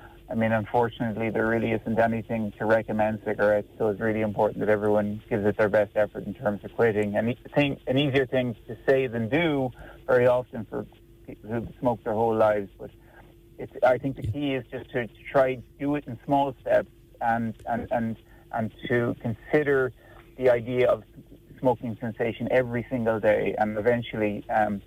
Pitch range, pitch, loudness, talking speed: 110-125 Hz, 115 Hz, -26 LUFS, 185 wpm